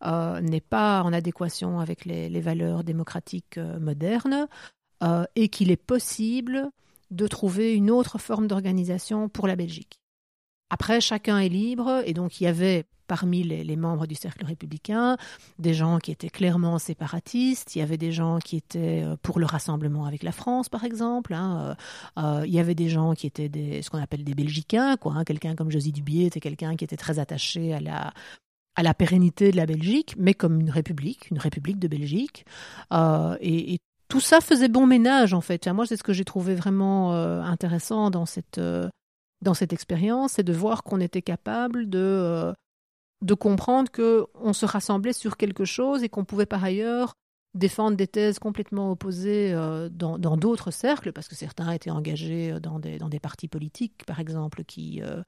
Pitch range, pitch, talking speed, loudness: 160-210 Hz, 175 Hz, 195 wpm, -25 LUFS